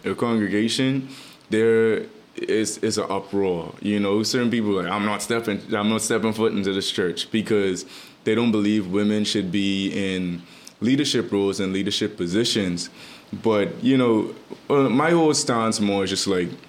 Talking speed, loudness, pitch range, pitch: 165 wpm, -22 LUFS, 100-115 Hz, 105 Hz